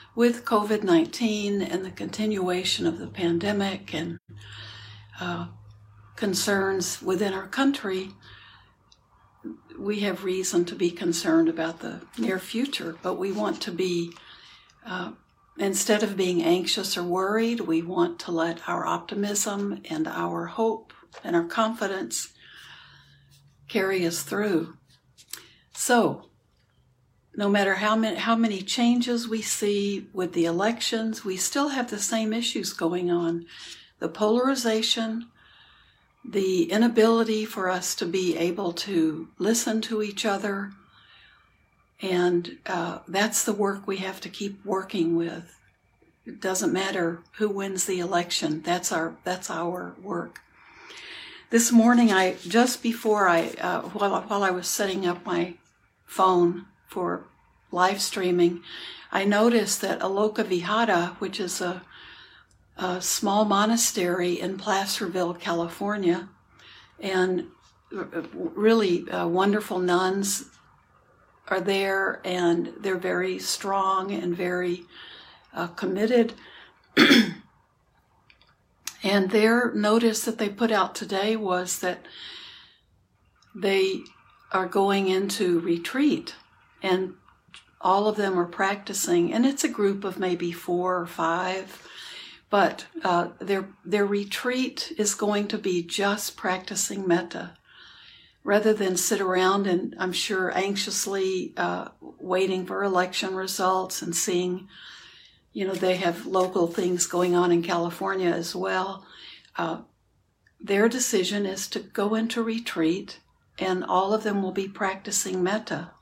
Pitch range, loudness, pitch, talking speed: 175-210 Hz, -25 LUFS, 190 Hz, 125 wpm